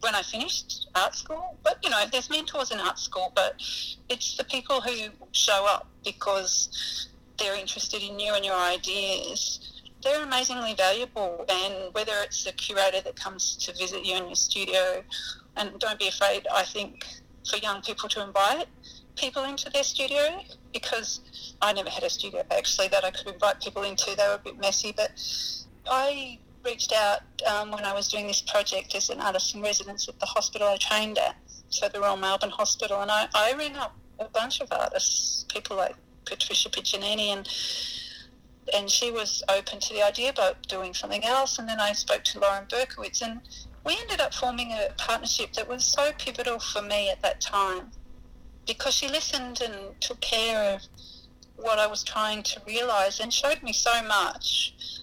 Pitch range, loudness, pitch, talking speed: 200-255 Hz, -27 LUFS, 210 Hz, 185 wpm